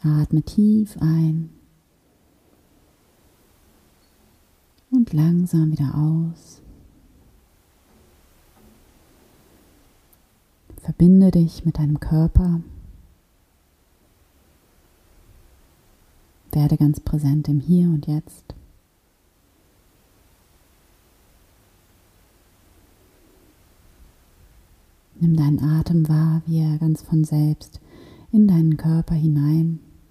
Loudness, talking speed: -19 LUFS, 65 wpm